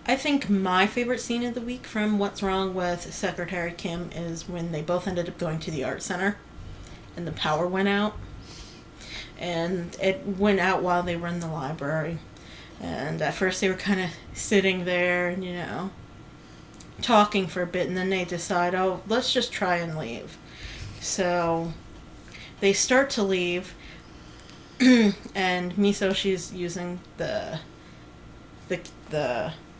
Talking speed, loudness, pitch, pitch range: 155 wpm, -26 LUFS, 185 Hz, 175-200 Hz